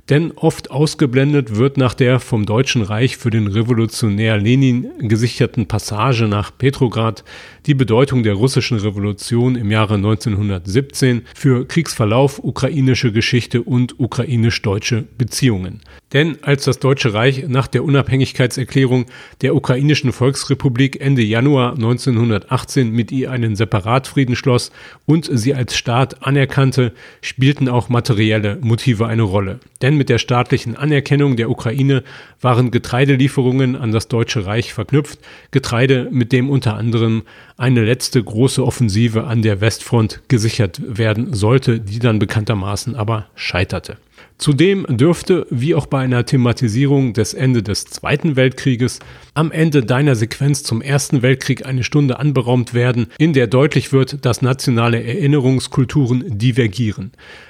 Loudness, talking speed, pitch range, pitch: -16 LUFS, 135 wpm, 115-135 Hz, 125 Hz